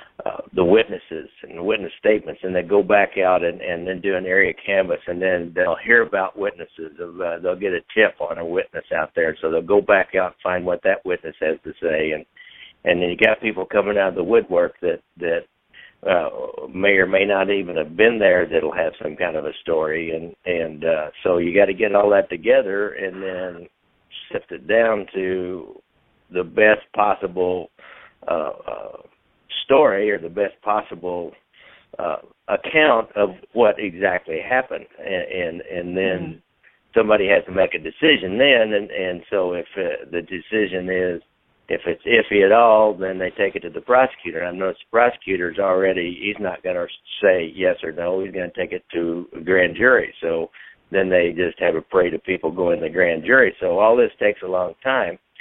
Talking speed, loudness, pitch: 200 wpm, -20 LUFS, 100 Hz